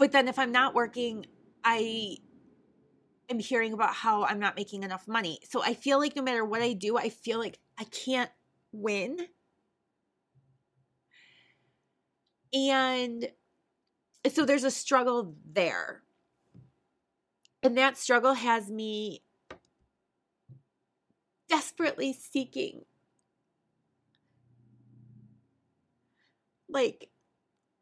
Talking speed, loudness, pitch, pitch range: 95 wpm, -29 LUFS, 230 Hz, 185-260 Hz